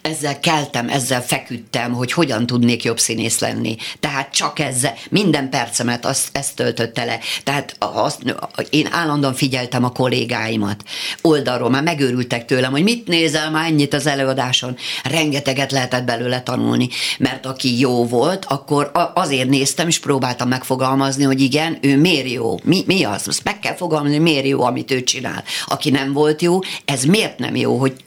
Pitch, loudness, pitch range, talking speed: 135 Hz, -18 LUFS, 125-150 Hz, 165 wpm